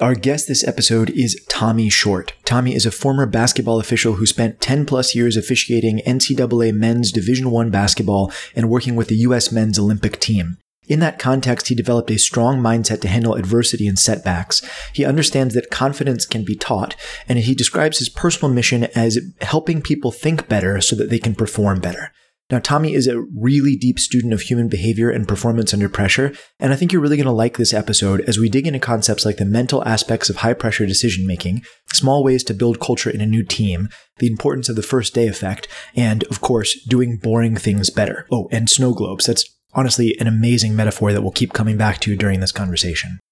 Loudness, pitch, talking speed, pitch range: -17 LUFS, 115 Hz, 205 wpm, 110-125 Hz